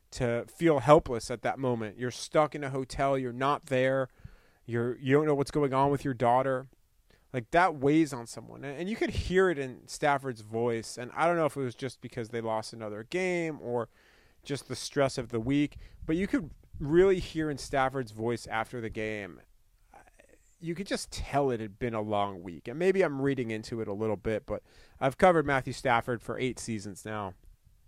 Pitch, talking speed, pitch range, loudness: 130 Hz, 205 wpm, 115-145 Hz, -30 LUFS